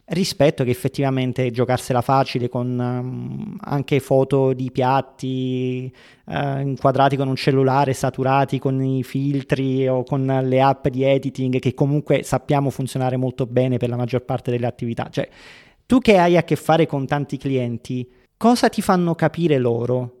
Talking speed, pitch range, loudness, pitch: 155 wpm, 125-140 Hz, -20 LUFS, 135 Hz